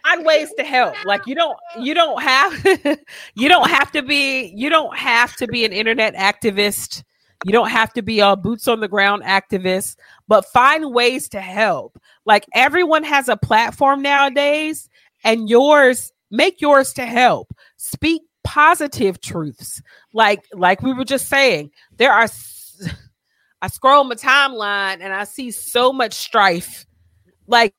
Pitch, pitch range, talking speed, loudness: 245 Hz, 205-290 Hz, 160 wpm, -16 LUFS